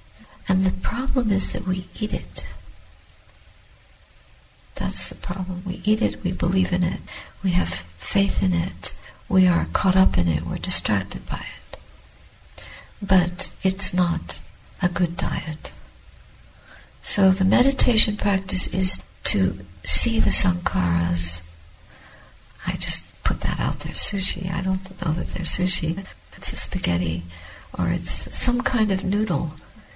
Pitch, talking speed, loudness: 150 Hz, 140 wpm, -23 LUFS